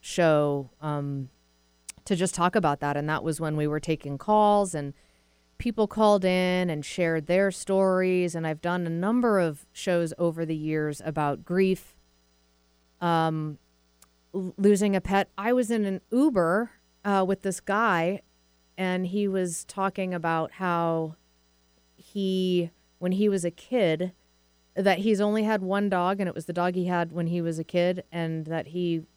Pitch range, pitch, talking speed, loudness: 150-190 Hz, 175 Hz, 170 wpm, -26 LUFS